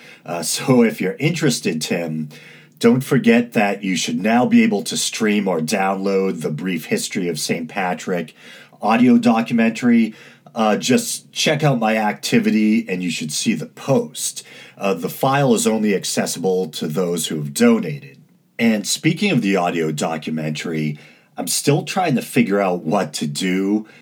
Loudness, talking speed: -19 LUFS, 160 wpm